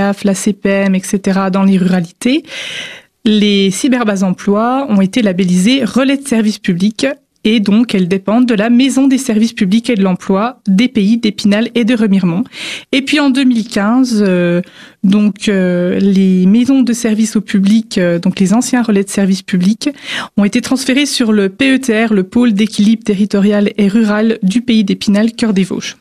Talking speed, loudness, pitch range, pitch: 170 wpm, -12 LUFS, 195-240 Hz, 215 Hz